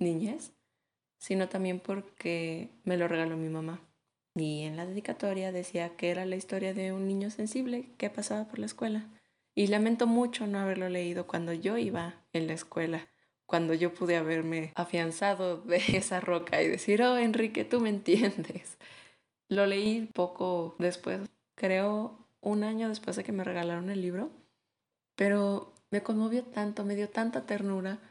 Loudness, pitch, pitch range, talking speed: -32 LUFS, 190 Hz, 170-210 Hz, 160 wpm